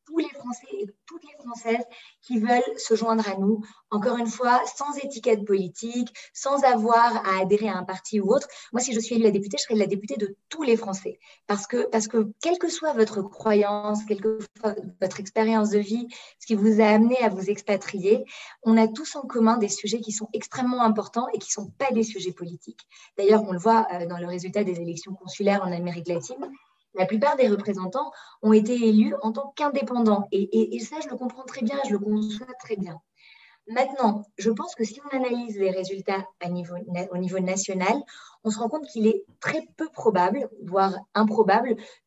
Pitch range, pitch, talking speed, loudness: 200-240 Hz, 220 Hz, 215 wpm, -25 LUFS